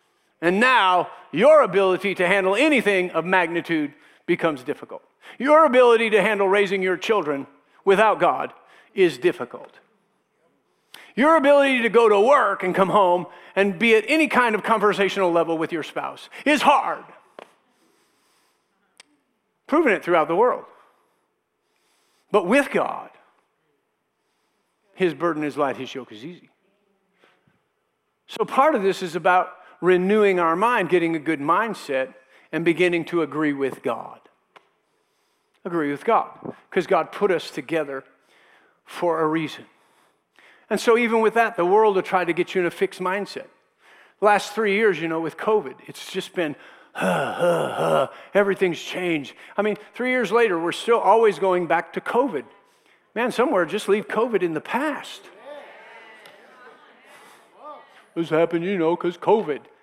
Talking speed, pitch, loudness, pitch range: 145 wpm, 195 Hz, -21 LUFS, 170-230 Hz